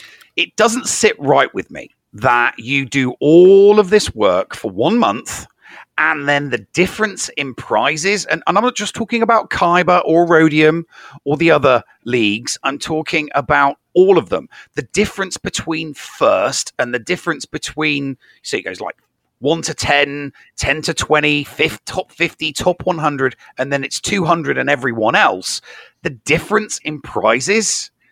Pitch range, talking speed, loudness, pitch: 145-195 Hz, 160 wpm, -15 LUFS, 155 Hz